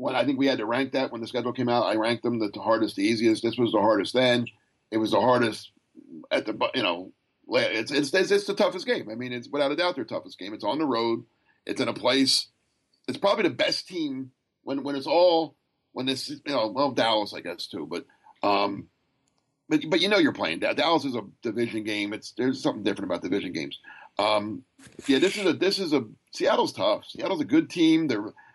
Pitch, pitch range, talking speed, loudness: 130 Hz, 115-180 Hz, 235 wpm, -26 LUFS